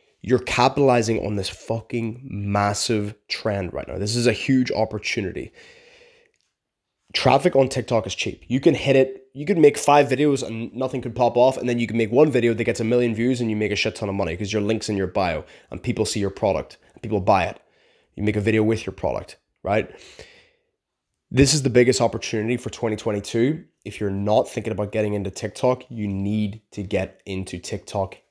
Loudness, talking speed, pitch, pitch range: -22 LUFS, 205 wpm, 115 Hz, 105-130 Hz